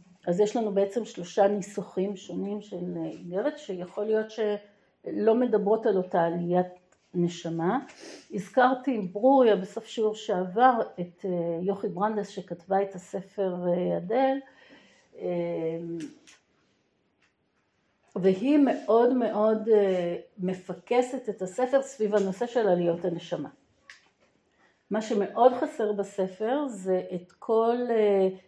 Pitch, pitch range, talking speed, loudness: 200 Hz, 180-230 Hz, 100 wpm, -27 LUFS